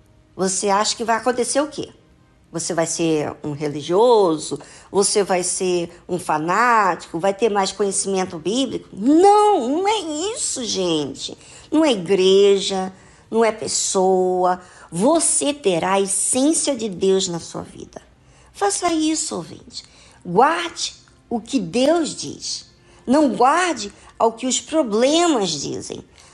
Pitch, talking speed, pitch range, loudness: 210 Hz, 130 wpm, 185-295 Hz, -19 LUFS